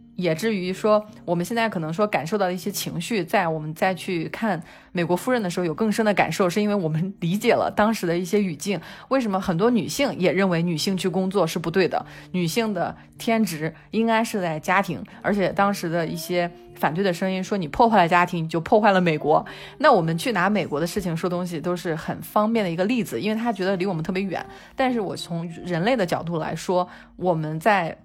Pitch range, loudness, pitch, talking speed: 170-210 Hz, -23 LUFS, 185 Hz, 335 characters per minute